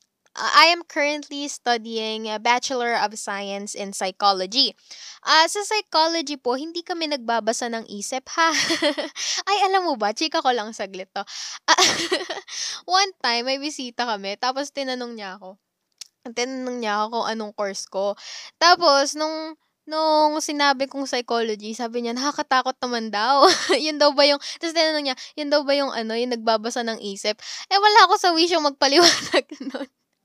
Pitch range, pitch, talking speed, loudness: 225-310 Hz, 270 Hz, 160 wpm, -21 LUFS